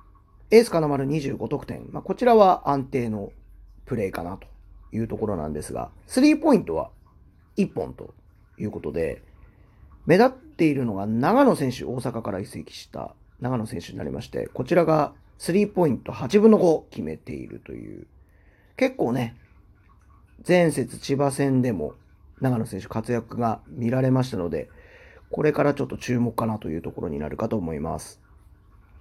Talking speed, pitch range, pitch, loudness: 310 characters per minute, 100-160 Hz, 125 Hz, -24 LUFS